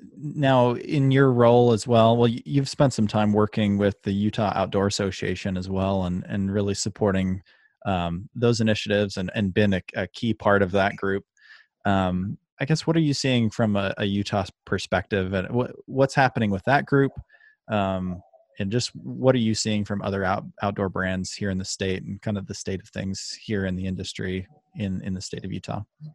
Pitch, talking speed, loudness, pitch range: 100 Hz, 200 wpm, -24 LUFS, 95-120 Hz